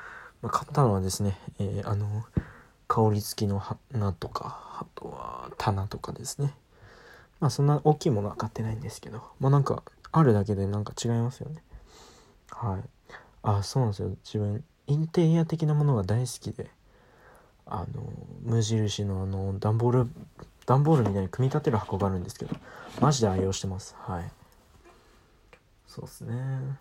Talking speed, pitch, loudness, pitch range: 325 characters per minute, 115 Hz, -28 LUFS, 100-140 Hz